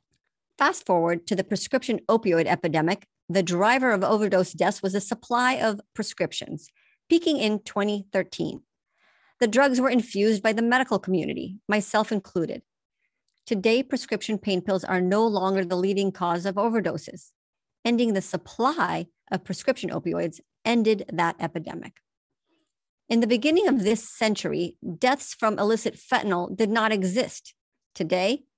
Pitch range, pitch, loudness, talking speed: 185-235 Hz, 210 Hz, -25 LUFS, 135 wpm